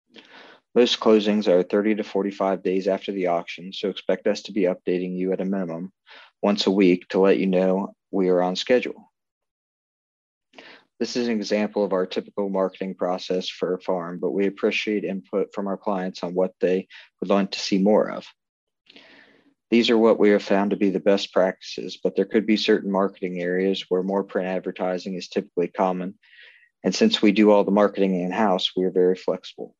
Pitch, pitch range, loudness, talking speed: 95 Hz, 95-105 Hz, -23 LUFS, 195 wpm